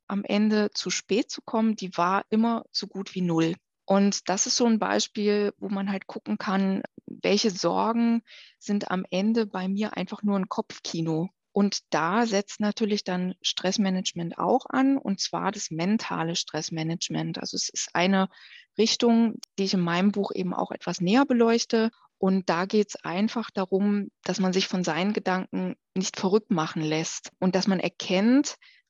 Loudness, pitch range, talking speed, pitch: -26 LUFS, 185-220 Hz, 170 wpm, 200 Hz